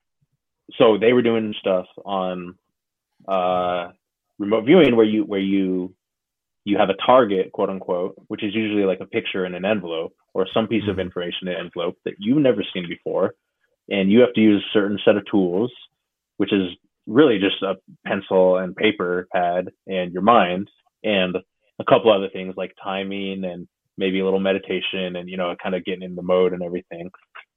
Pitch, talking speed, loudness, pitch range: 95 Hz, 185 wpm, -21 LUFS, 90-105 Hz